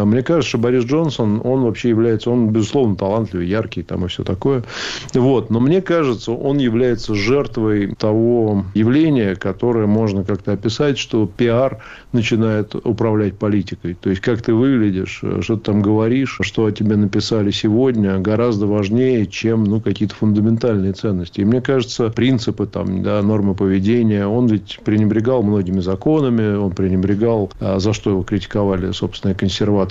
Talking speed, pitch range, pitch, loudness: 155 wpm, 100-120 Hz, 110 Hz, -17 LUFS